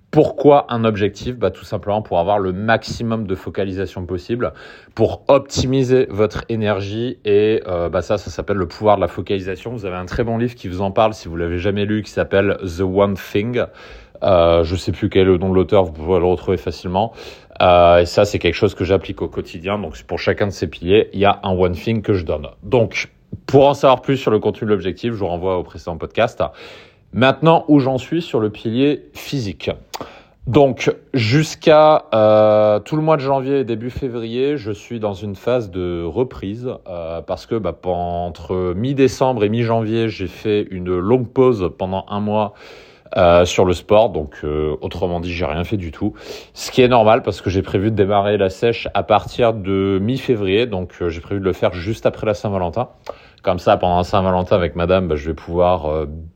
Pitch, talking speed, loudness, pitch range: 100 Hz, 210 wpm, -18 LUFS, 90-115 Hz